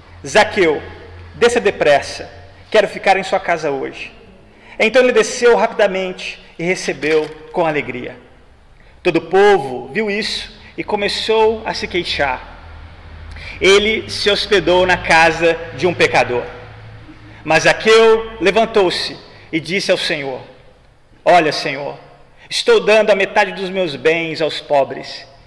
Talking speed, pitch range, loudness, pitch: 125 wpm, 150-210 Hz, -15 LUFS, 180 Hz